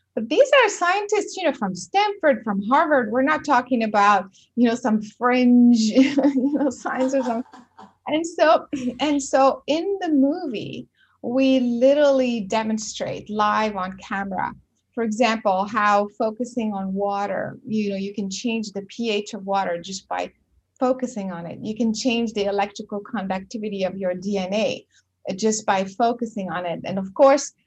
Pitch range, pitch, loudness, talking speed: 200-270 Hz, 230 Hz, -22 LUFS, 160 wpm